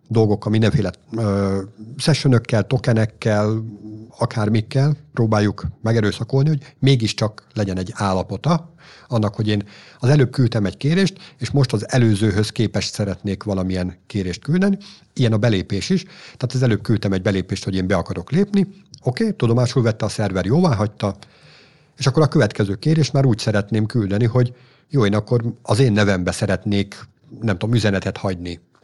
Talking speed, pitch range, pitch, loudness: 155 wpm, 105-135 Hz, 110 Hz, -20 LUFS